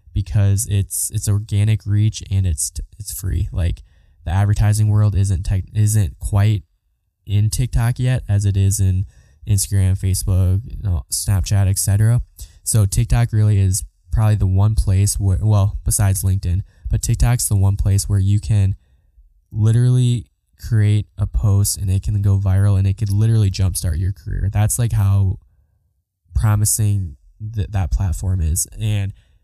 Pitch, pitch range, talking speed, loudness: 100 Hz, 95-105 Hz, 155 wpm, -18 LUFS